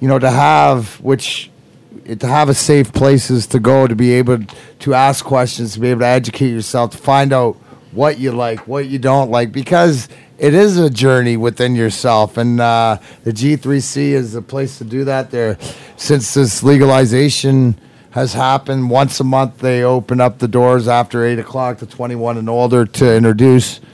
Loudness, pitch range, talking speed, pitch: -13 LUFS, 120-135 Hz, 185 wpm, 130 Hz